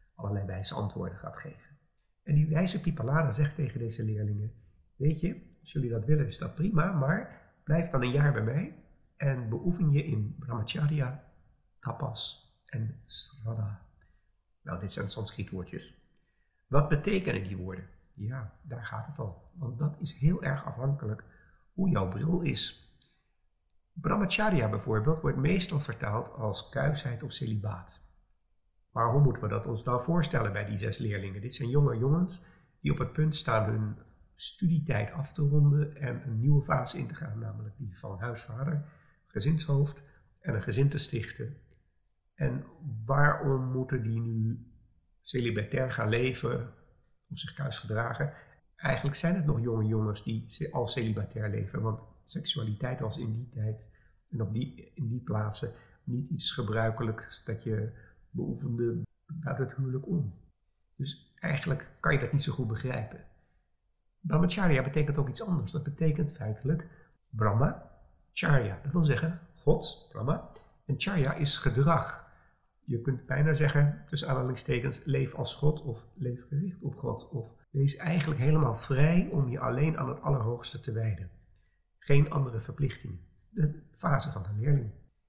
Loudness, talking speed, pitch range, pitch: -31 LUFS, 155 wpm, 110-150 Hz, 130 Hz